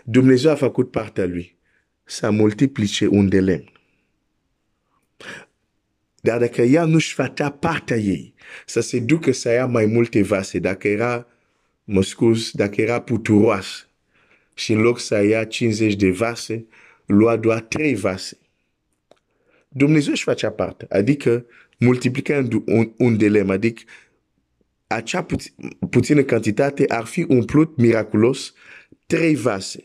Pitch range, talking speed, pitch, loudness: 105-130 Hz, 85 wpm, 115 Hz, -19 LUFS